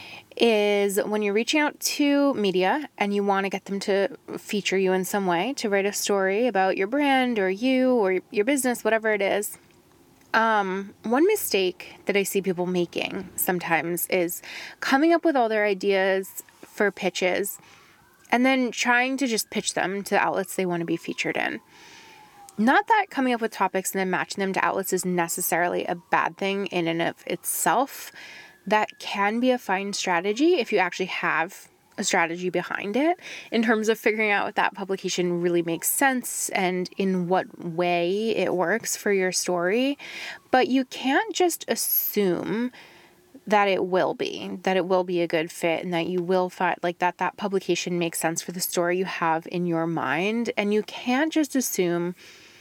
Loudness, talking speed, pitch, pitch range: -24 LUFS, 185 wpm, 195 Hz, 180-235 Hz